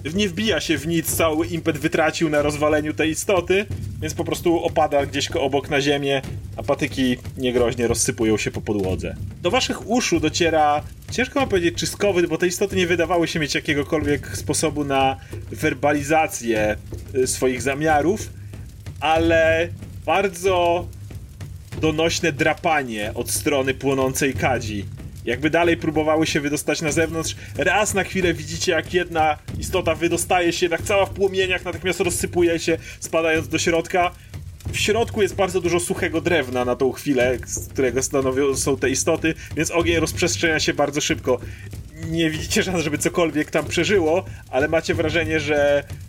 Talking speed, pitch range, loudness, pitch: 150 wpm, 125-170 Hz, -21 LUFS, 155 Hz